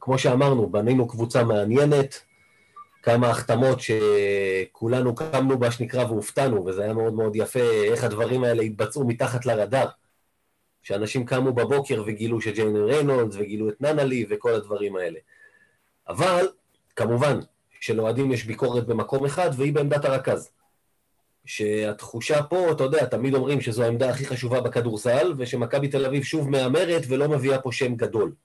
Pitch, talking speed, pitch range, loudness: 125 Hz, 140 wpm, 115-140 Hz, -23 LUFS